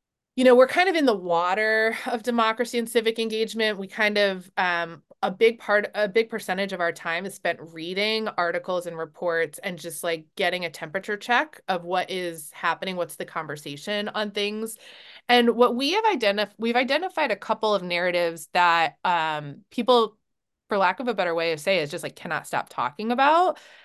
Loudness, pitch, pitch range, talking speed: -24 LUFS, 205 Hz, 175-230 Hz, 195 wpm